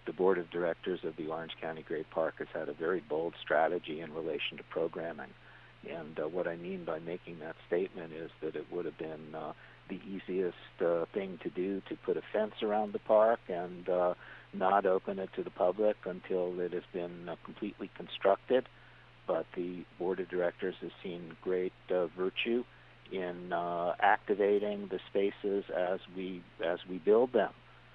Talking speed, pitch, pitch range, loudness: 185 wpm, 90 Hz, 85-100 Hz, -35 LUFS